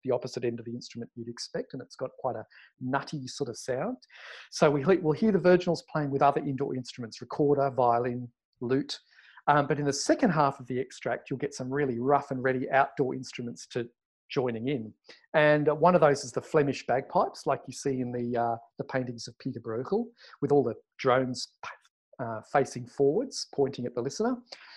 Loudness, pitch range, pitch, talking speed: -29 LUFS, 125-145 Hz, 135 Hz, 200 wpm